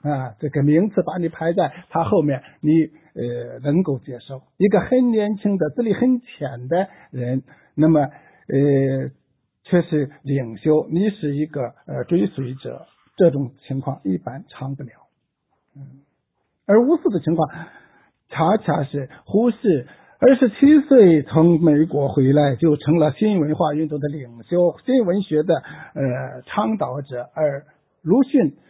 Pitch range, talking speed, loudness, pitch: 140-180 Hz, 205 characters per minute, -19 LUFS, 155 Hz